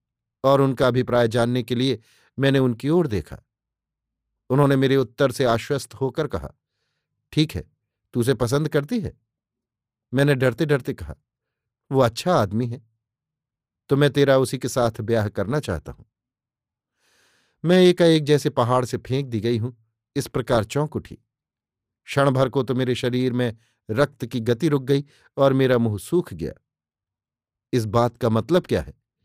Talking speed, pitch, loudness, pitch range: 160 wpm, 125 Hz, -22 LUFS, 115-140 Hz